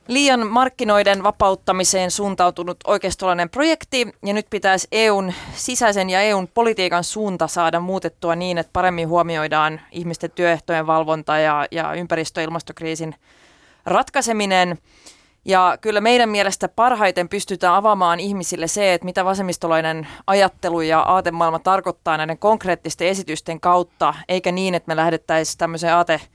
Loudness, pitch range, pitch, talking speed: -19 LUFS, 165-200 Hz, 180 Hz, 130 wpm